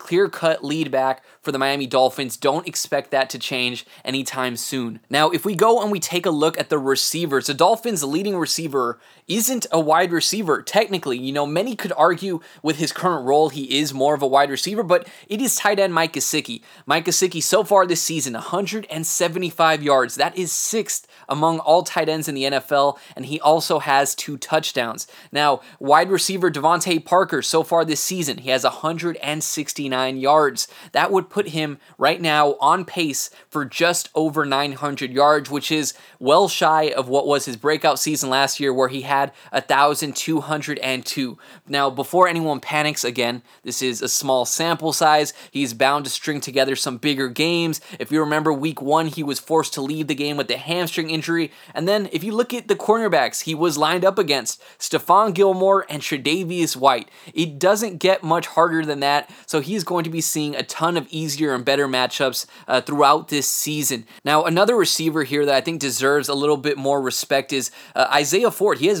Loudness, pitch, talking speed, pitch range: -20 LUFS, 155 Hz, 190 wpm, 140-170 Hz